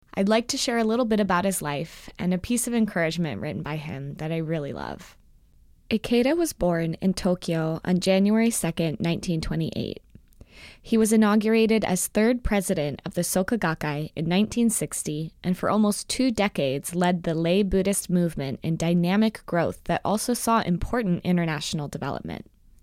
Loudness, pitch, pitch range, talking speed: -25 LUFS, 180 Hz, 165-220 Hz, 165 wpm